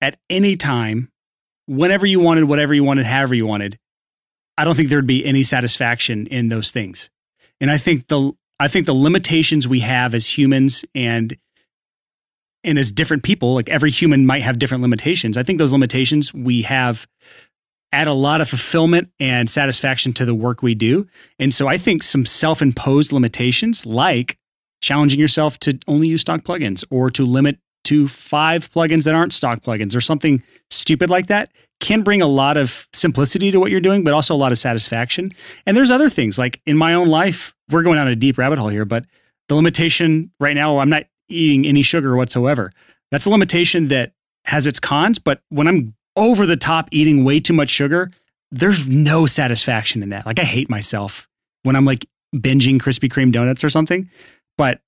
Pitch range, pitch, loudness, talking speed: 125-160 Hz, 140 Hz, -16 LUFS, 190 wpm